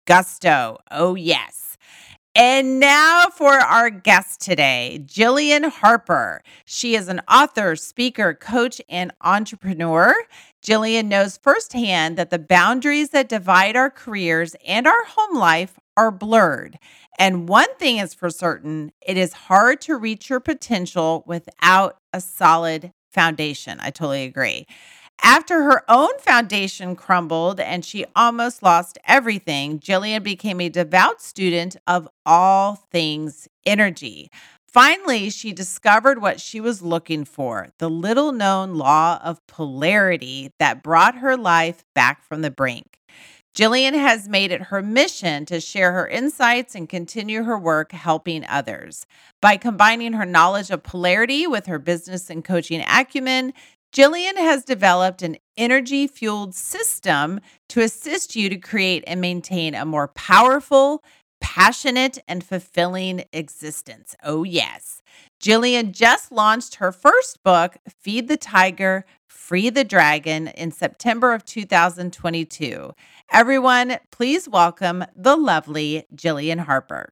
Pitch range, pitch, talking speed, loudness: 170-240 Hz, 190 Hz, 130 wpm, -18 LUFS